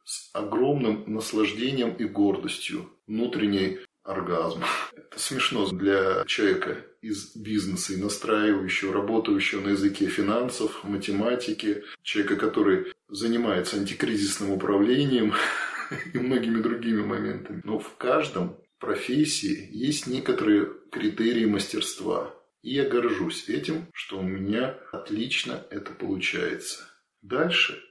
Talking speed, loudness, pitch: 105 wpm, -27 LUFS, 110 Hz